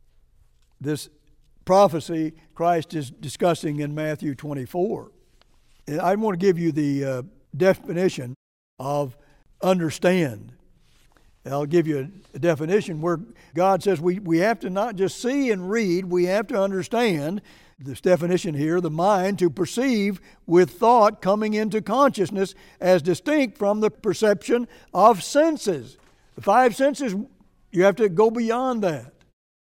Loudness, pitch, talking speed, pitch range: -22 LUFS, 180 Hz, 135 wpm, 155-205 Hz